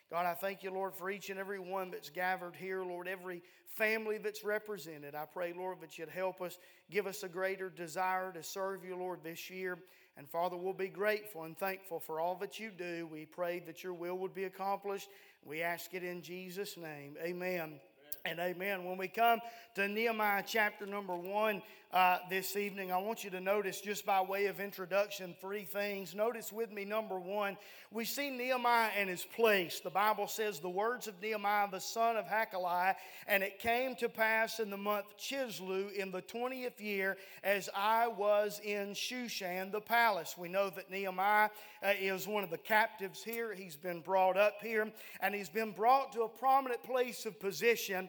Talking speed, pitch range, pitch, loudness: 195 wpm, 185-215 Hz, 195 Hz, -36 LUFS